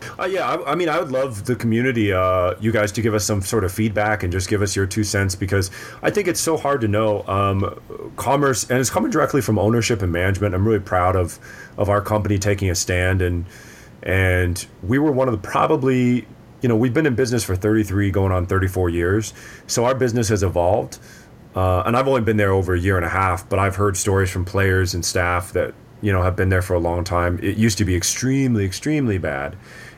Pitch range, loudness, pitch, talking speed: 95-115 Hz, -20 LUFS, 105 Hz, 250 wpm